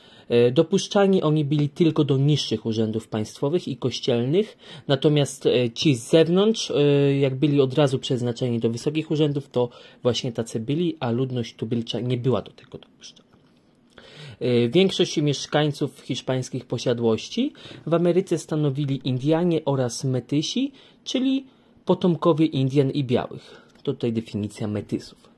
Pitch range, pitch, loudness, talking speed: 125-160 Hz, 140 Hz, -23 LUFS, 125 wpm